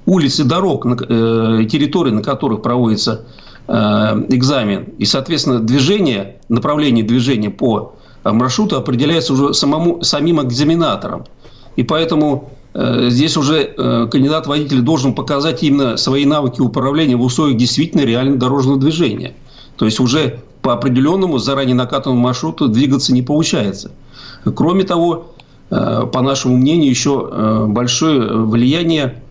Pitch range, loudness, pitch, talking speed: 125-150 Hz, -14 LUFS, 135 Hz, 115 wpm